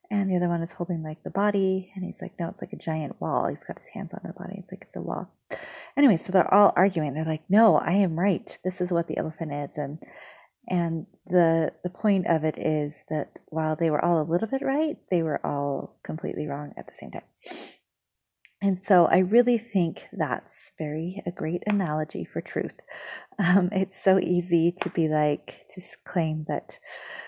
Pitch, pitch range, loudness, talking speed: 175 Hz, 160-195 Hz, -26 LUFS, 210 wpm